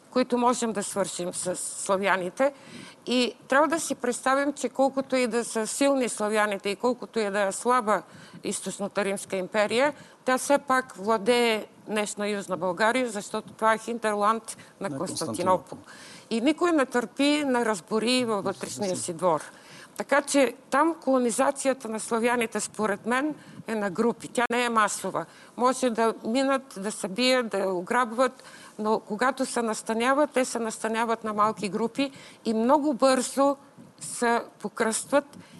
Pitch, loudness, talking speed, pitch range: 230 Hz, -26 LUFS, 145 wpm, 205-260 Hz